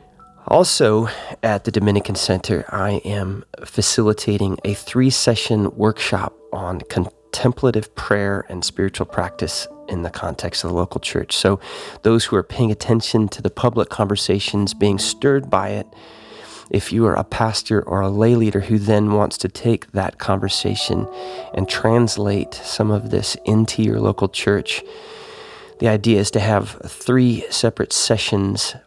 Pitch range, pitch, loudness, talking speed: 100-115 Hz, 105 Hz, -19 LUFS, 150 wpm